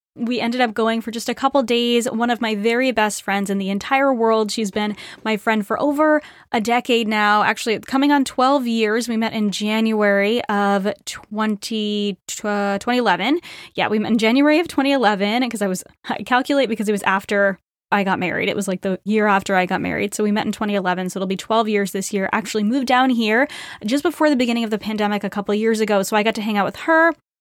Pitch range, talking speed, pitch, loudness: 205-245 Hz, 230 wpm, 220 Hz, -19 LUFS